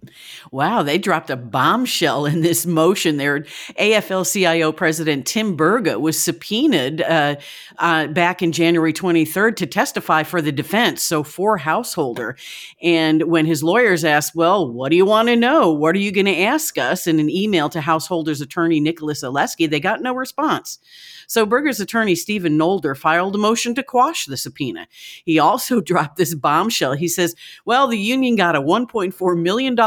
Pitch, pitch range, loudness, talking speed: 175 Hz, 160-215 Hz, -18 LUFS, 175 wpm